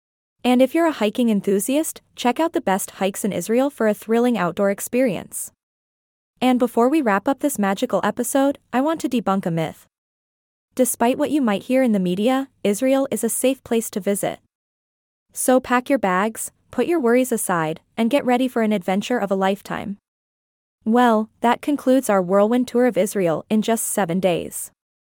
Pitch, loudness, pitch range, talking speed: 225 Hz, -20 LUFS, 195-255 Hz, 180 wpm